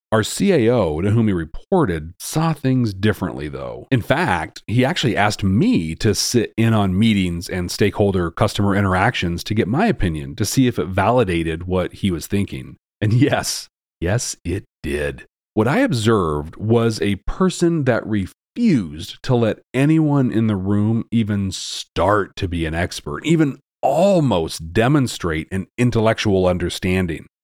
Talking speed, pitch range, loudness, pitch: 150 wpm, 90-115 Hz, -19 LUFS, 100 Hz